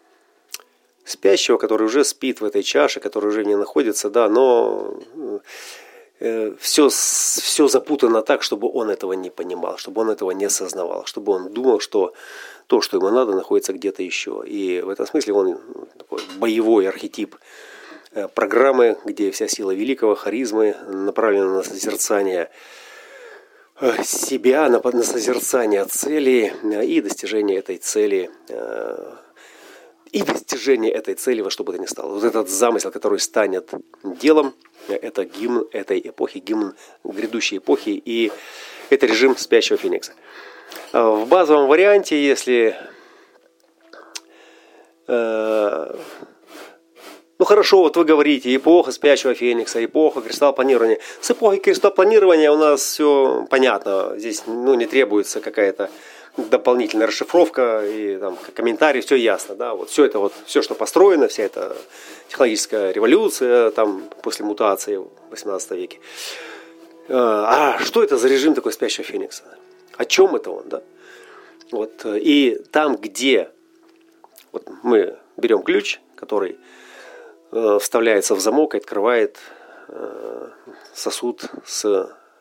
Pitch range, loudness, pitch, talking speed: 325-440 Hz, -18 LUFS, 395 Hz, 125 wpm